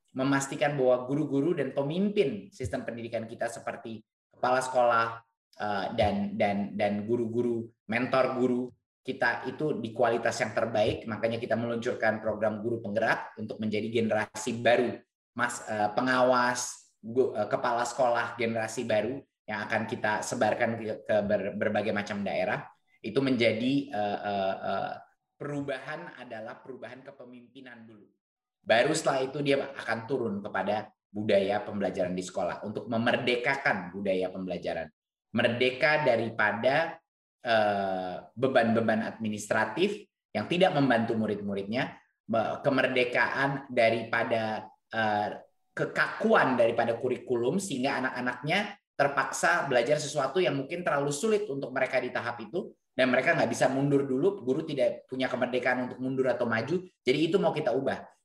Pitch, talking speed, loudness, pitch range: 120 Hz, 130 wpm, -29 LUFS, 110-135 Hz